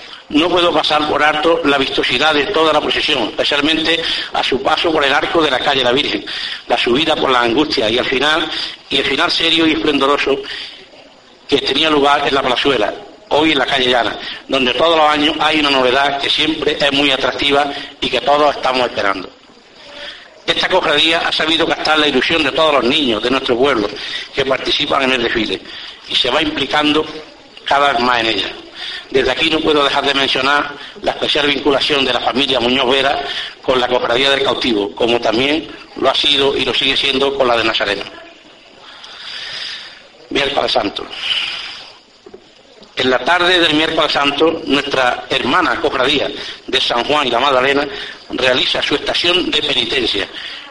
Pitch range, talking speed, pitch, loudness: 135-160 Hz, 175 wpm, 145 Hz, -14 LUFS